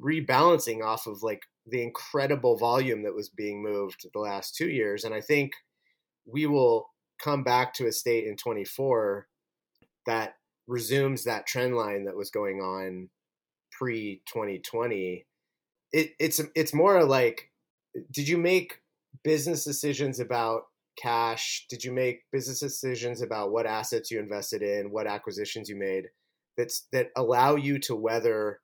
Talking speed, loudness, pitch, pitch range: 150 wpm, -28 LUFS, 125 Hz, 110-150 Hz